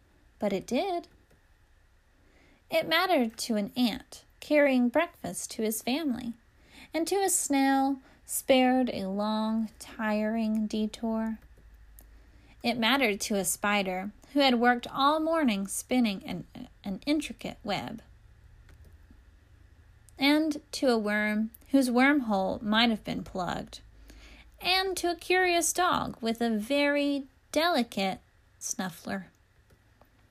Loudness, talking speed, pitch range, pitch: -28 LUFS, 115 wpm, 205-285 Hz, 235 Hz